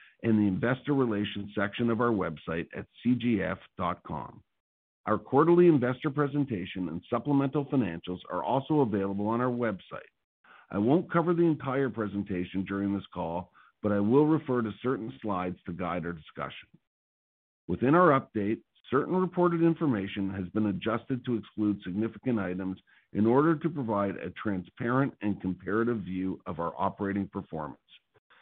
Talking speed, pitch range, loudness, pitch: 145 wpm, 95-130 Hz, -29 LUFS, 110 Hz